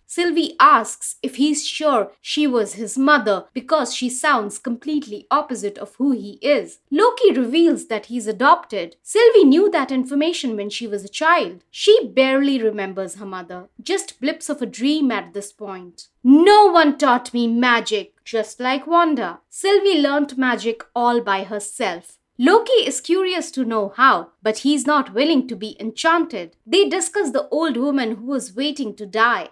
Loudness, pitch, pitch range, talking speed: -18 LUFS, 265 Hz, 225-315 Hz, 165 wpm